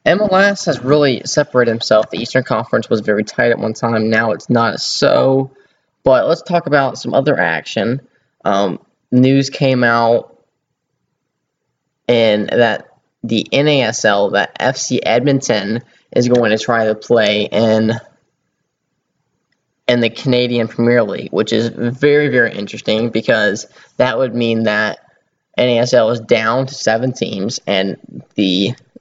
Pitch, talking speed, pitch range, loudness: 120 Hz, 135 wpm, 110-130 Hz, -15 LUFS